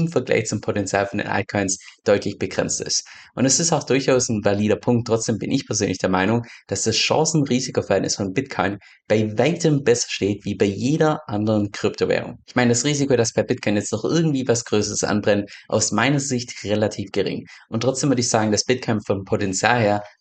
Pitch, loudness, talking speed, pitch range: 115 Hz, -21 LUFS, 195 wpm, 105-125 Hz